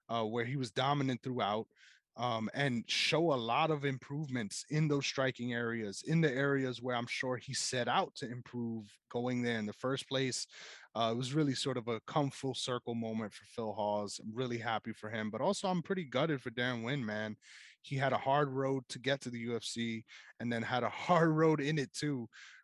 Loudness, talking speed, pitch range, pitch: -35 LUFS, 215 wpm, 115-140 Hz, 125 Hz